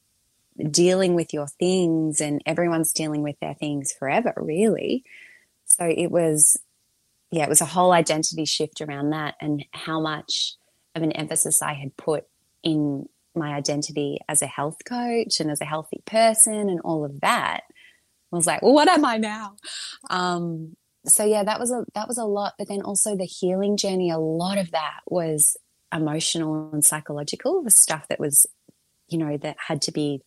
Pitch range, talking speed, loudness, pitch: 150-185 Hz, 180 wpm, -22 LUFS, 160 Hz